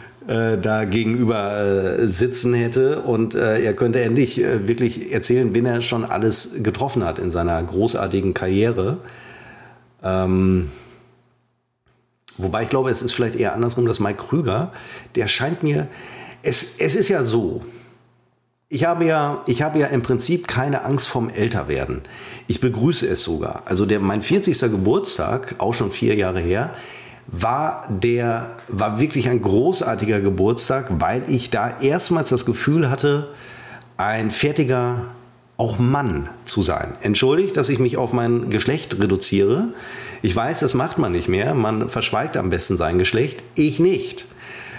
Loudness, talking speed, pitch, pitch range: -20 LUFS, 155 wpm, 120 Hz, 110-130 Hz